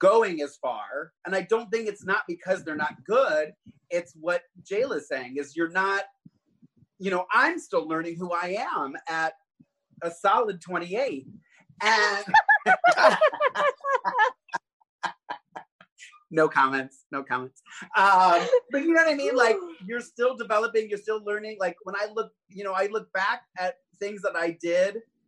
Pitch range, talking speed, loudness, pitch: 175-240 Hz, 155 wpm, -25 LUFS, 195 Hz